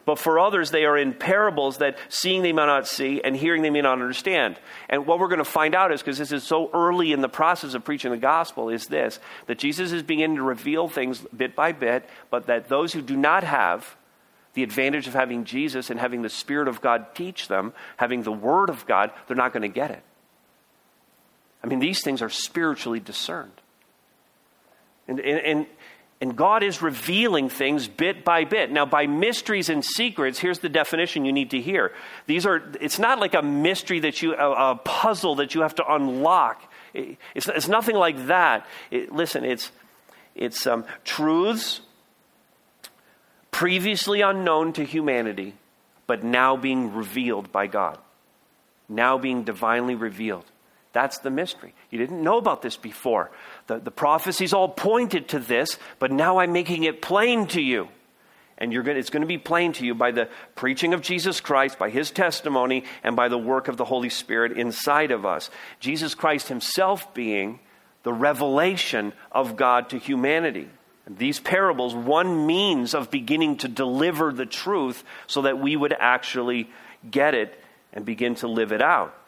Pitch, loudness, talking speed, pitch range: 145 Hz, -23 LUFS, 180 wpm, 125-175 Hz